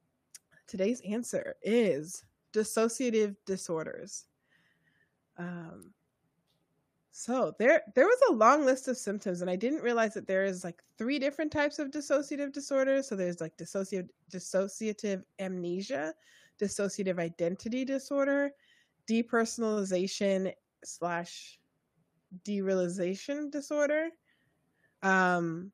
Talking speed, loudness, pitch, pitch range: 100 wpm, -31 LUFS, 210 Hz, 185-270 Hz